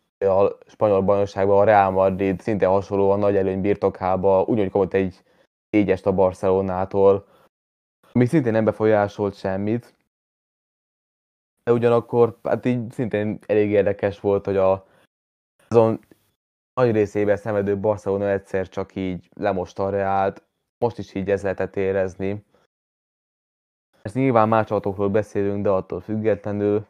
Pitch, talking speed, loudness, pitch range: 100 Hz, 125 wpm, -21 LUFS, 95-105 Hz